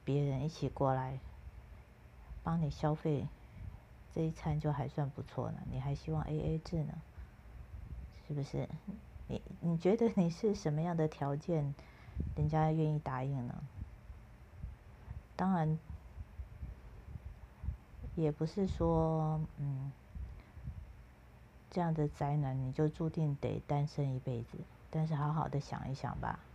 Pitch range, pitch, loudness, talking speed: 130-160 Hz, 150 Hz, -37 LUFS, 180 characters per minute